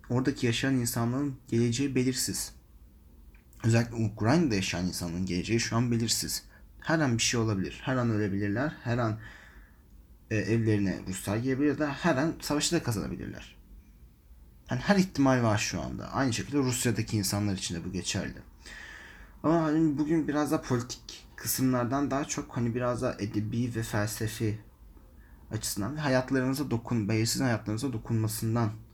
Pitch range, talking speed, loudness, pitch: 95-130 Hz, 145 wpm, -29 LUFS, 115 Hz